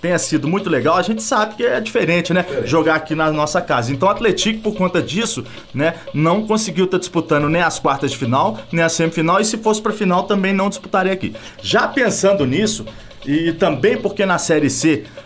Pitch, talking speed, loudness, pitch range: 175 Hz, 210 wpm, -17 LUFS, 155-200 Hz